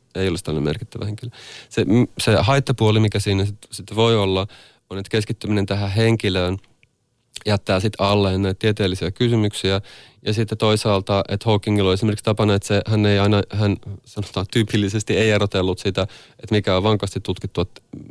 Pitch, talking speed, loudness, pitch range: 105 Hz, 165 wpm, -20 LUFS, 95-110 Hz